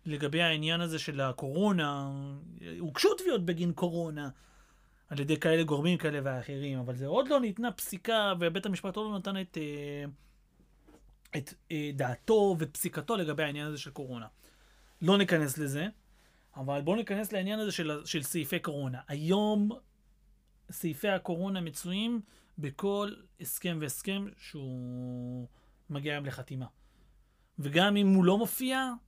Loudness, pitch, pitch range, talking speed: -32 LUFS, 165 Hz, 145-195 Hz, 130 wpm